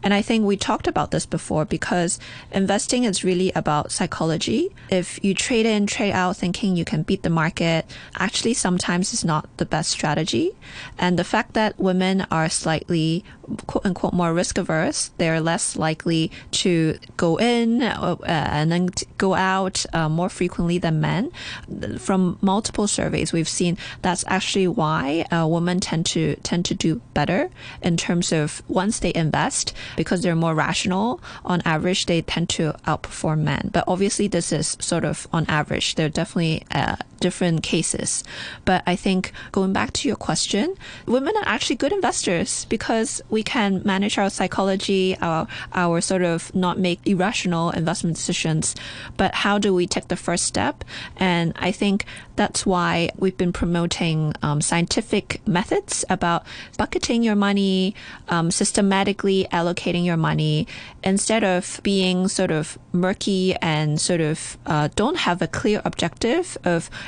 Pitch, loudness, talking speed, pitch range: 180 Hz, -22 LUFS, 160 wpm, 165-195 Hz